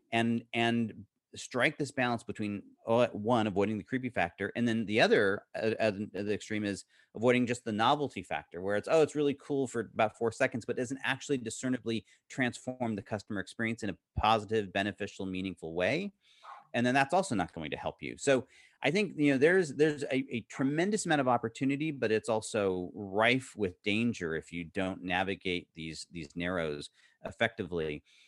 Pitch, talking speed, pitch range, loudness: 115 Hz, 185 wpm, 100-130 Hz, -32 LUFS